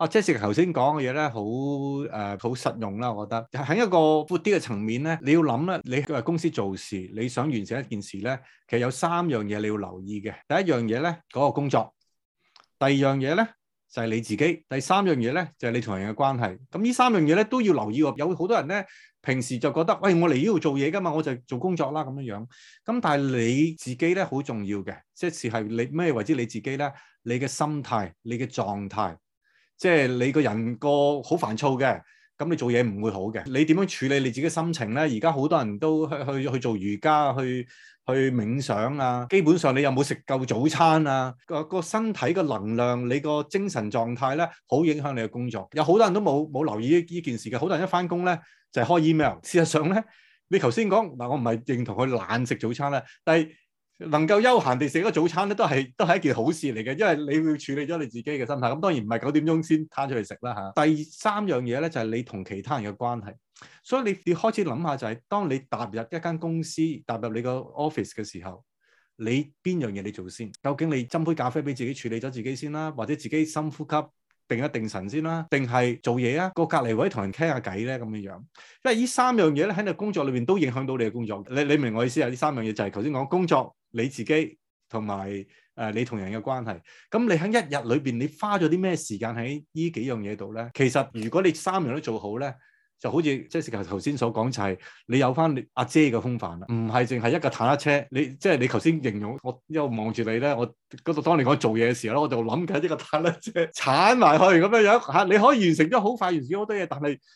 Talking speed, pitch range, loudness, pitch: 345 characters per minute, 115-165 Hz, -25 LUFS, 140 Hz